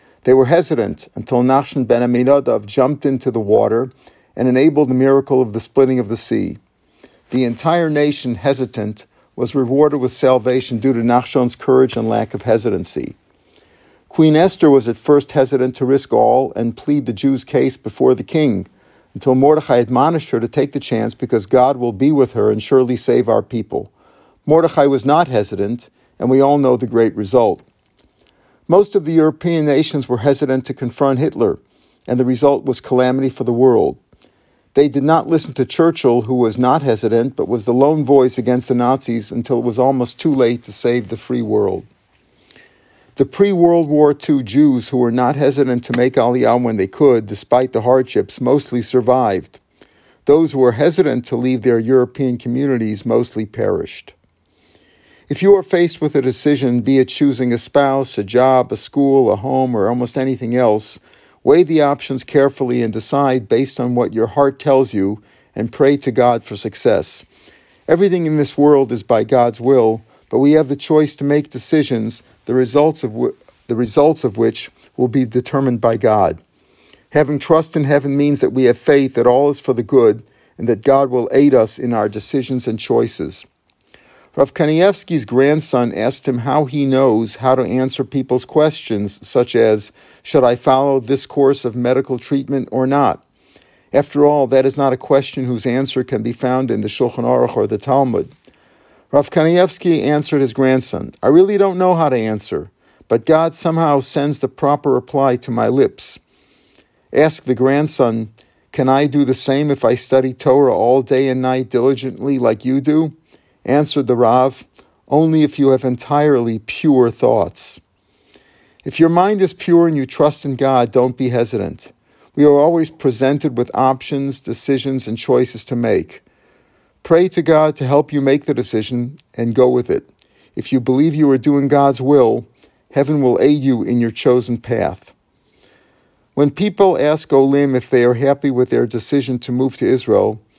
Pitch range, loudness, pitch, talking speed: 125-145 Hz, -15 LUFS, 130 Hz, 180 wpm